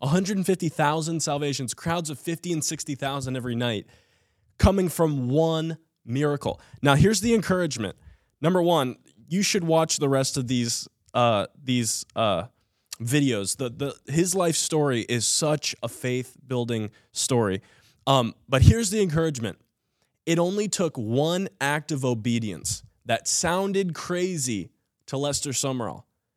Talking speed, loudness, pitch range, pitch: 135 wpm, -25 LUFS, 120-165 Hz, 140 Hz